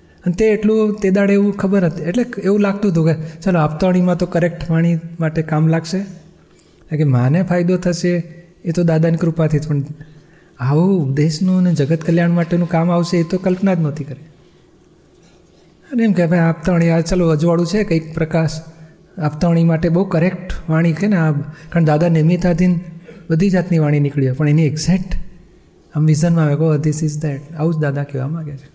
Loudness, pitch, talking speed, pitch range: -16 LUFS, 170 Hz, 185 wpm, 155-180 Hz